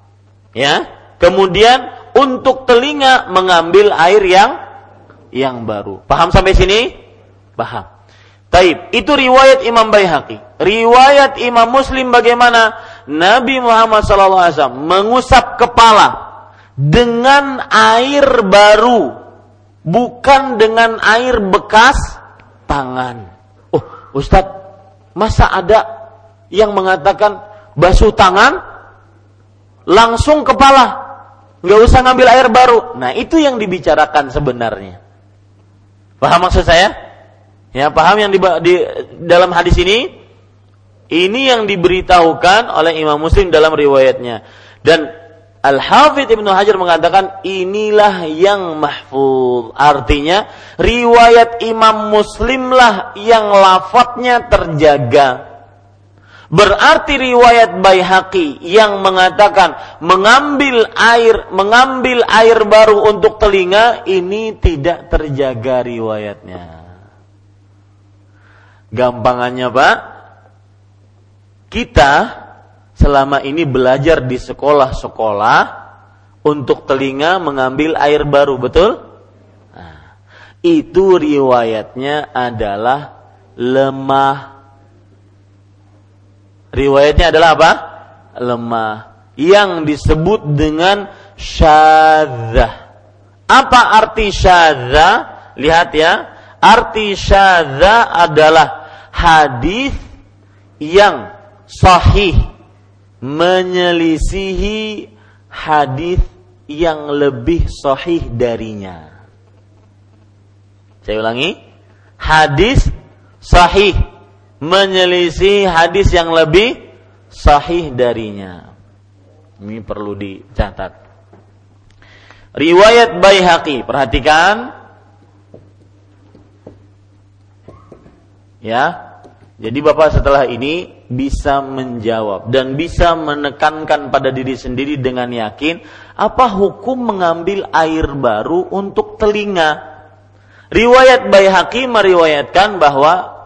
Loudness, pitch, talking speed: -10 LUFS, 150 Hz, 80 wpm